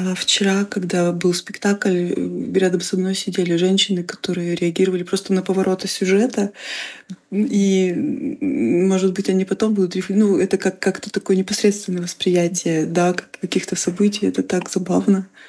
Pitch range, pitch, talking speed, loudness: 185-200 Hz, 190 Hz, 130 wpm, -19 LUFS